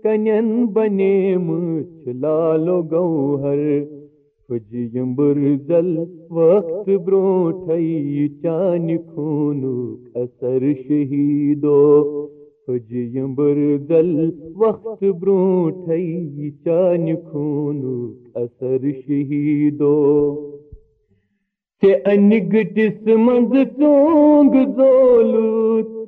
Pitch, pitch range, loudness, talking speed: 160 Hz, 145-195 Hz, -17 LUFS, 60 wpm